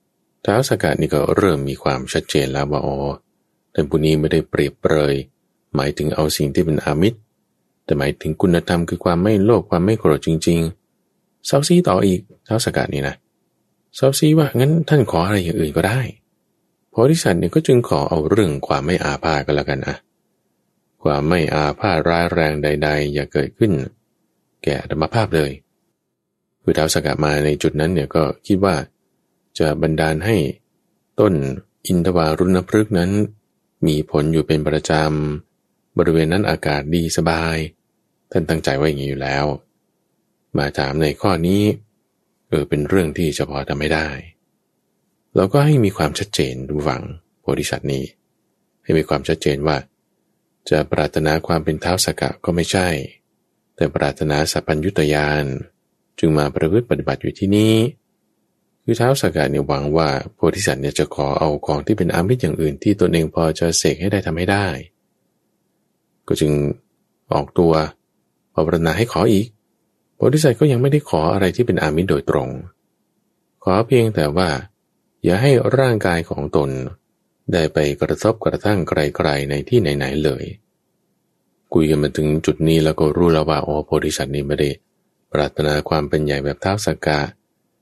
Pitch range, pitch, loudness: 75-95 Hz, 80 Hz, -18 LUFS